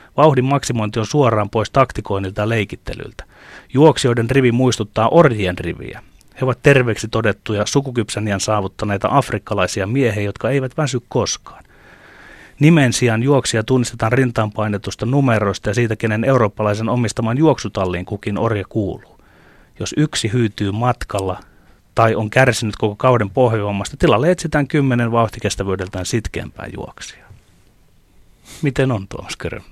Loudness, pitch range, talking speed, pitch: -17 LUFS, 105-130 Hz, 120 wpm, 115 Hz